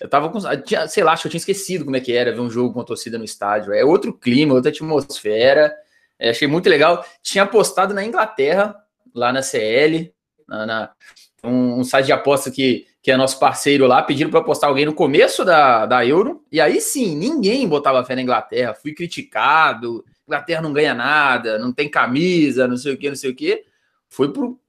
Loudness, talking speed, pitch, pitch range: -17 LUFS, 210 wpm, 150 Hz, 130-200 Hz